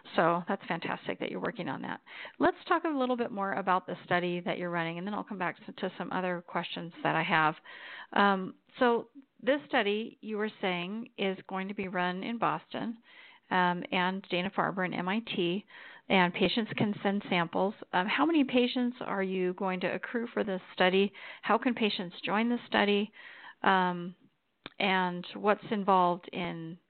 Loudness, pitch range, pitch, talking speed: -31 LUFS, 180-220 Hz, 195 Hz, 180 wpm